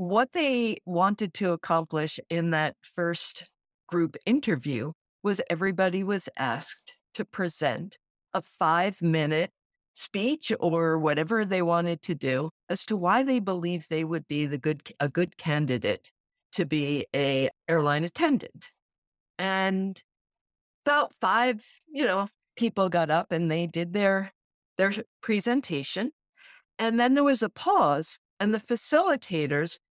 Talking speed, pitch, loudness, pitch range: 135 wpm, 185 Hz, -27 LUFS, 160-220 Hz